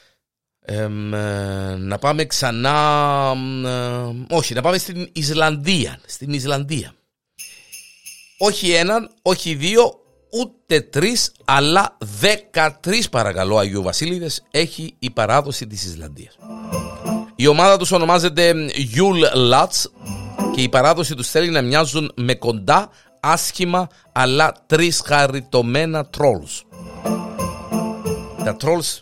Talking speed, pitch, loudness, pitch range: 105 wpm, 150 Hz, -18 LUFS, 125-175 Hz